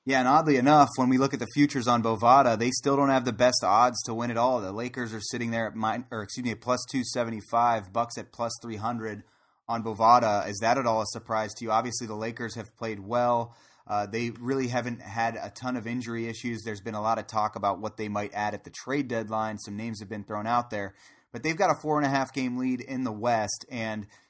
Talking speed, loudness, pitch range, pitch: 250 wpm, -27 LUFS, 110-125 Hz, 115 Hz